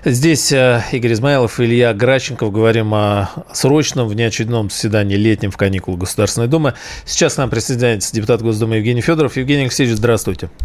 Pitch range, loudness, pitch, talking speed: 110-130 Hz, -15 LUFS, 115 Hz, 150 wpm